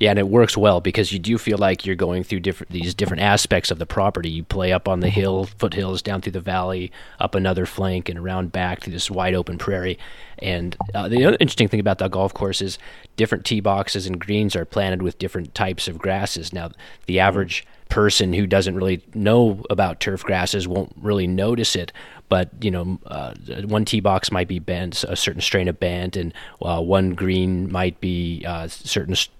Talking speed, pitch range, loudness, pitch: 210 wpm, 90-100 Hz, -21 LUFS, 95 Hz